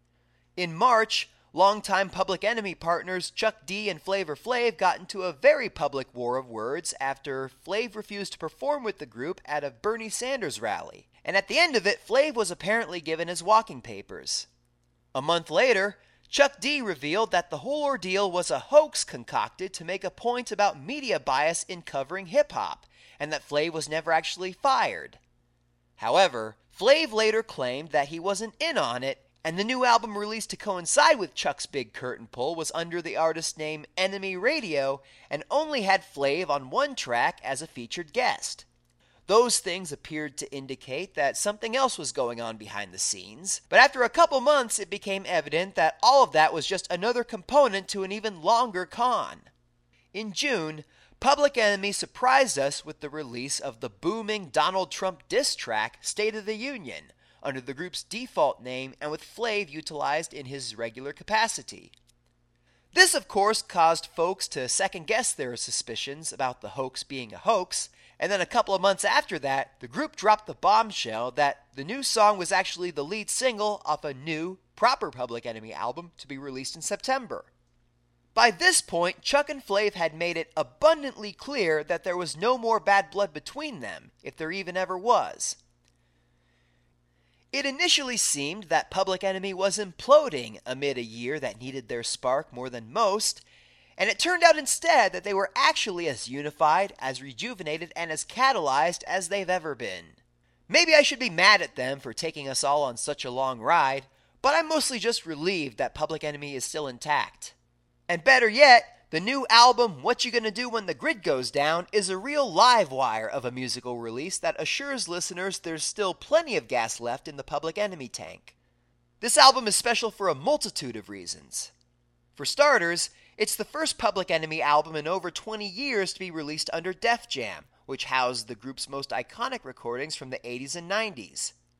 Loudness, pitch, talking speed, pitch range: -26 LUFS, 175 Hz, 185 wpm, 135-220 Hz